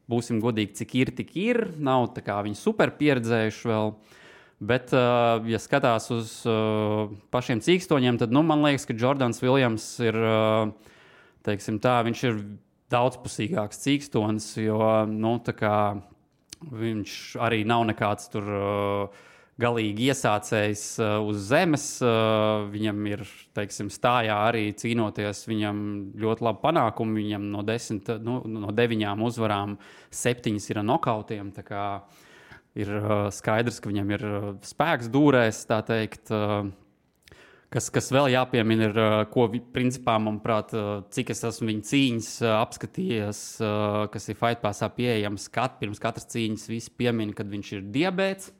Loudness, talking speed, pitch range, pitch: -26 LUFS, 115 wpm, 105-120 Hz, 110 Hz